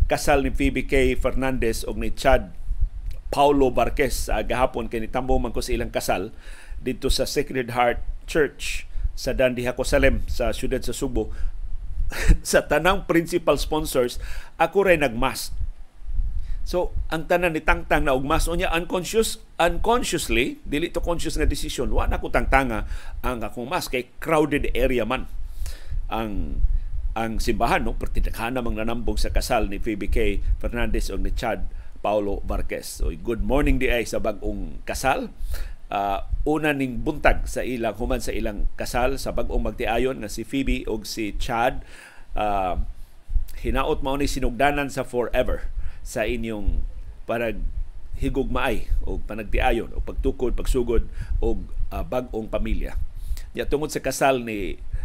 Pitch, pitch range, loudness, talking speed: 120 Hz, 95-135 Hz, -25 LUFS, 145 wpm